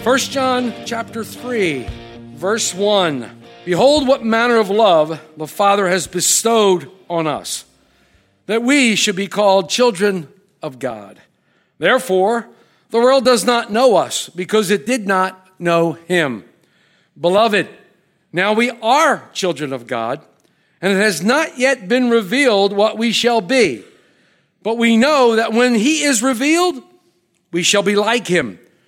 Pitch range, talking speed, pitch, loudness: 175-240 Hz, 145 wpm, 205 Hz, -15 LUFS